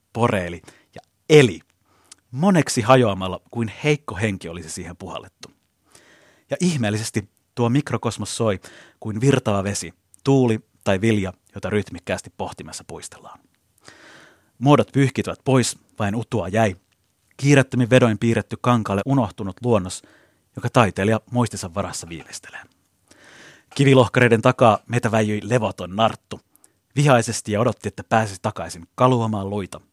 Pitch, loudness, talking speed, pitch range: 110 Hz, -20 LUFS, 115 wpm, 100-125 Hz